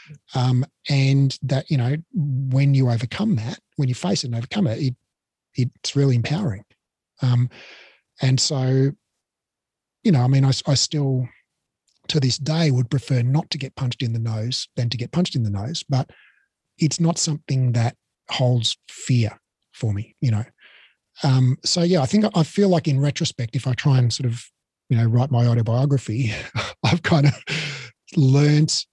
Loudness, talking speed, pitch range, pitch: -21 LUFS, 175 wpm, 120-150 Hz, 135 Hz